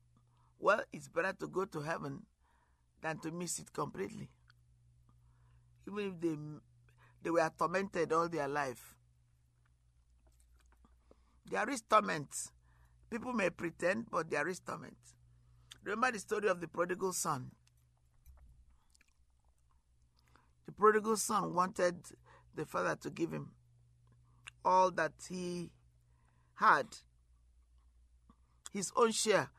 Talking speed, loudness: 110 wpm, -36 LUFS